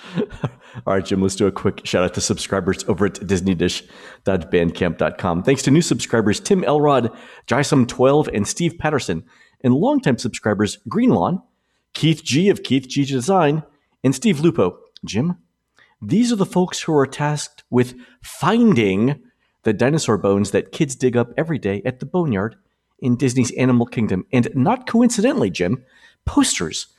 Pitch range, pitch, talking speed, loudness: 110-165 Hz, 130 Hz, 150 wpm, -19 LUFS